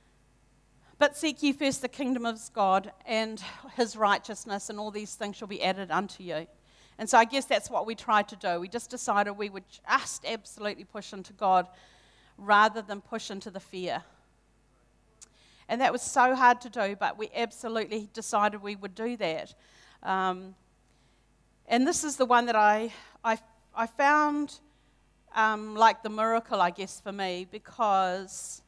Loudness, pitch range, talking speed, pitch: -28 LUFS, 195-230 Hz, 170 wpm, 210 Hz